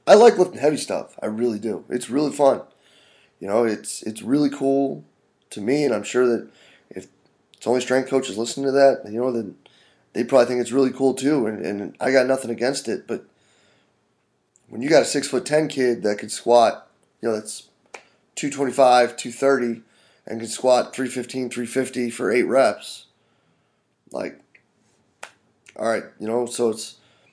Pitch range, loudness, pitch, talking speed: 115-135 Hz, -21 LUFS, 125 Hz, 175 wpm